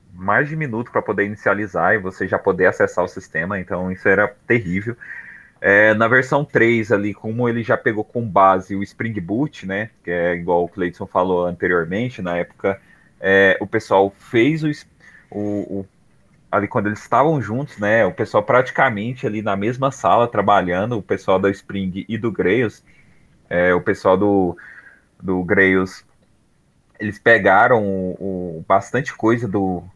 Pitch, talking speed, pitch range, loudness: 100 Hz, 165 wpm, 95-115 Hz, -18 LUFS